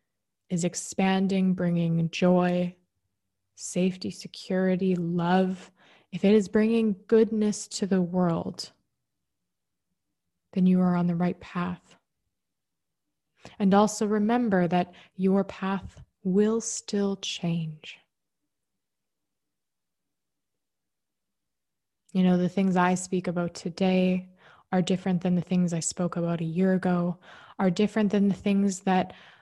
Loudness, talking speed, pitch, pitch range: -26 LUFS, 115 wpm, 185 Hz, 175-195 Hz